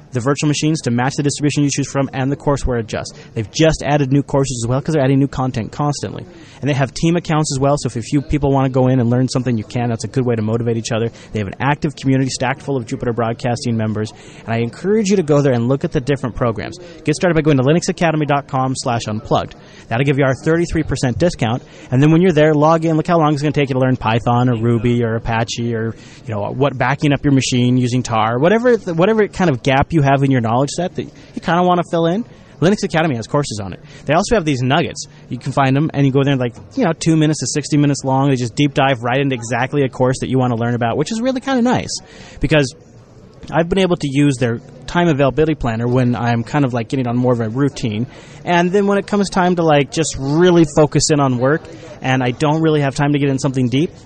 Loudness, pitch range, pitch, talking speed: -16 LUFS, 125-155 Hz, 140 Hz, 265 wpm